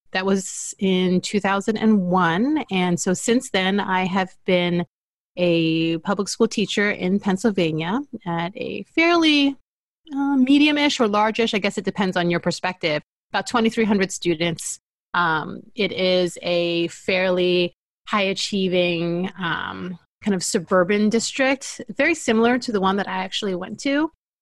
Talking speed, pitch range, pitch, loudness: 145 wpm, 180-230 Hz, 195 Hz, -21 LUFS